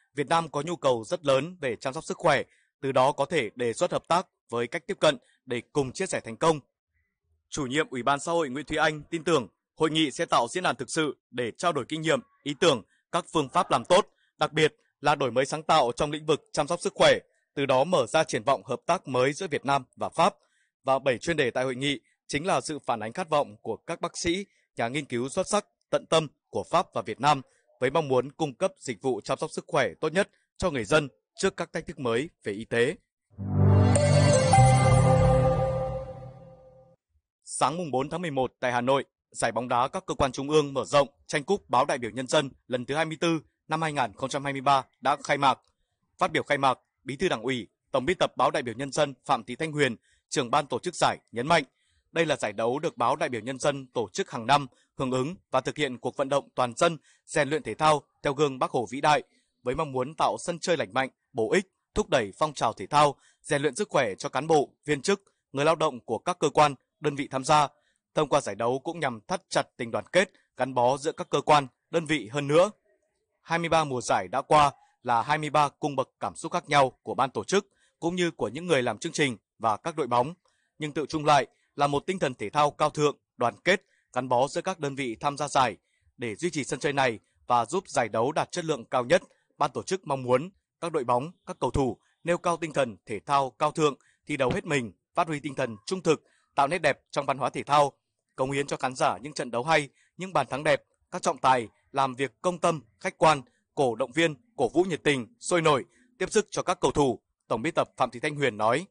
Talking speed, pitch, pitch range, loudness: 245 wpm, 145 Hz, 130-165 Hz, -27 LUFS